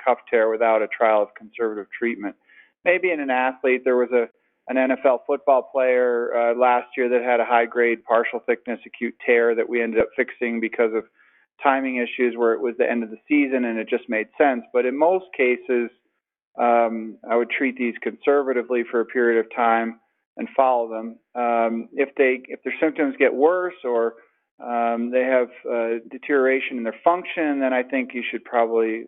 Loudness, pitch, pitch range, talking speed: -22 LUFS, 120 Hz, 115-130 Hz, 195 wpm